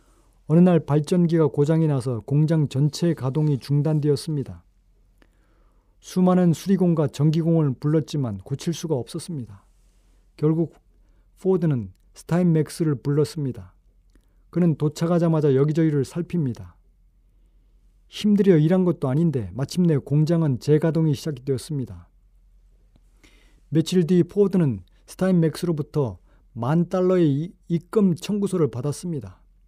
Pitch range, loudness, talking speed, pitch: 110-170 Hz, -22 LUFS, 285 characters per minute, 150 Hz